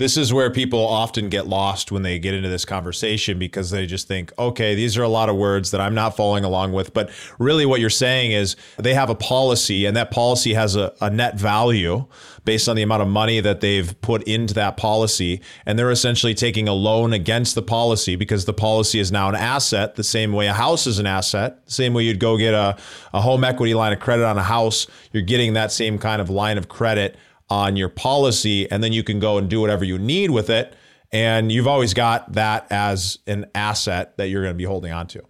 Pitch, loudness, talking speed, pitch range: 110 Hz, -19 LUFS, 240 wpm, 100-115 Hz